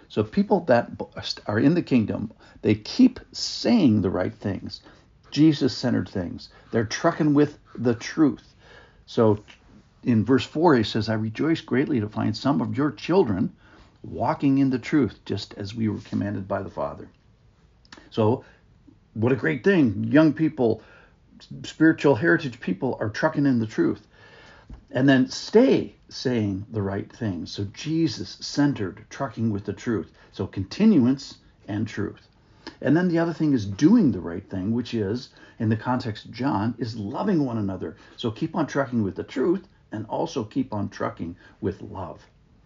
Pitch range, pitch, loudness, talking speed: 105-140 Hz, 115 Hz, -24 LUFS, 165 wpm